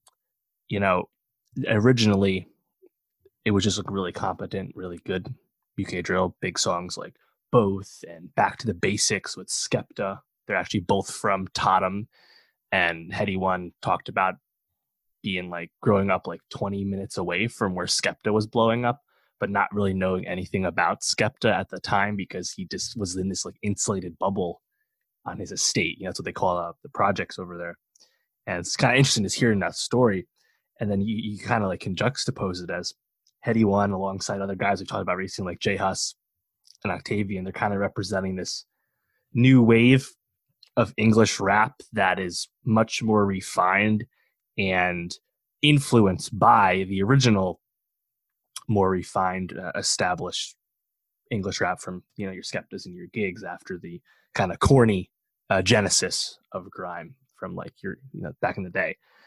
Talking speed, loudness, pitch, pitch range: 170 wpm, -24 LUFS, 100 Hz, 95-115 Hz